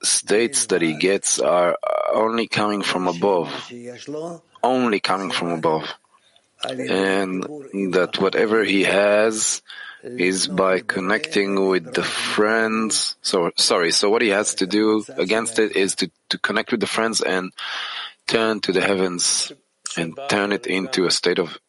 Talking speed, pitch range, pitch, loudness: 145 wpm, 95-110 Hz, 100 Hz, -20 LUFS